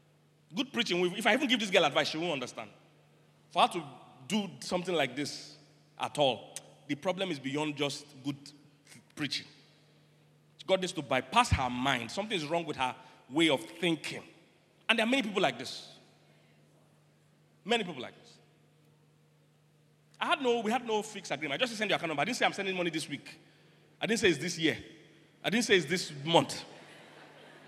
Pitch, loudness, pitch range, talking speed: 160 Hz, -31 LUFS, 145-195 Hz, 195 wpm